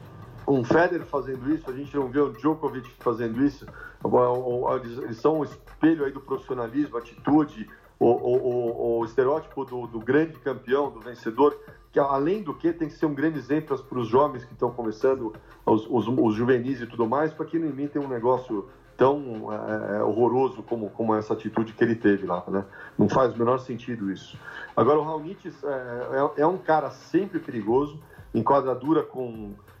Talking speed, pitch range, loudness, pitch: 185 wpm, 115-150 Hz, -26 LUFS, 130 Hz